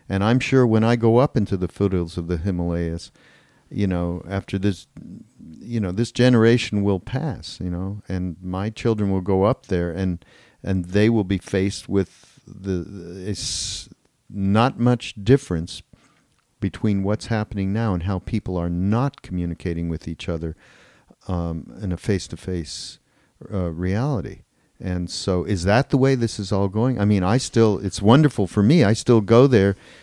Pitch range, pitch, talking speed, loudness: 90-115 Hz, 100 Hz, 170 wpm, -21 LUFS